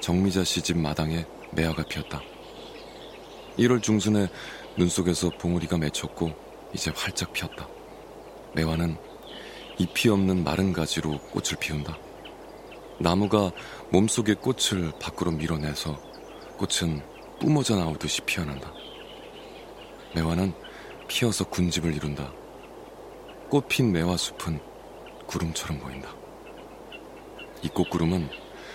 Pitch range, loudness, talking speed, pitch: 80-95 Hz, -27 LUFS, 230 characters per minute, 85 Hz